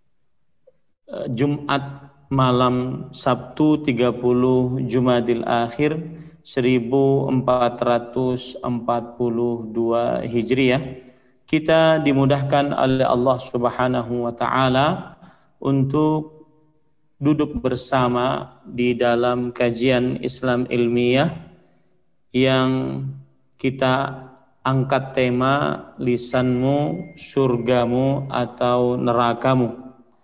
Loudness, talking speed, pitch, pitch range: -20 LUFS, 65 wpm, 130 Hz, 120-135 Hz